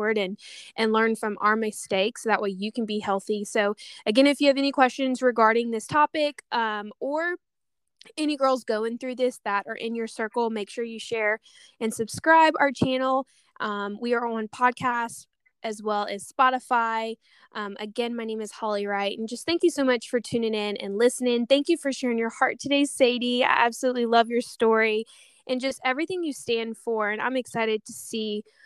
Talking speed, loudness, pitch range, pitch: 195 wpm, -25 LUFS, 215-260 Hz, 230 Hz